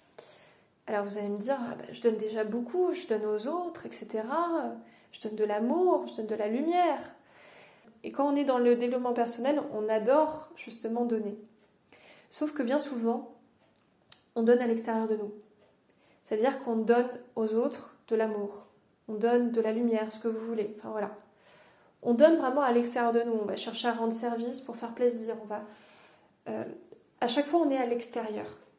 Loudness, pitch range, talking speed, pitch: -30 LUFS, 220-260 Hz, 190 wpm, 235 Hz